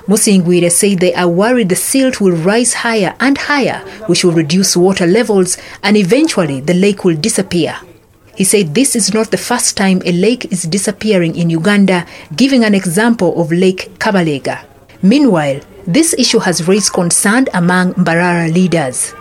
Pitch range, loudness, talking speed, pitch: 175-220 Hz, -11 LUFS, 160 wpm, 190 Hz